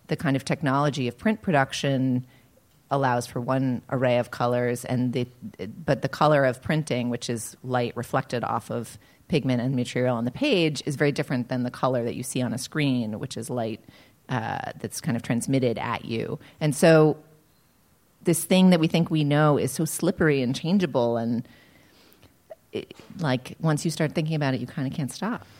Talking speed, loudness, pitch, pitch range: 190 wpm, -25 LUFS, 135 Hz, 125-155 Hz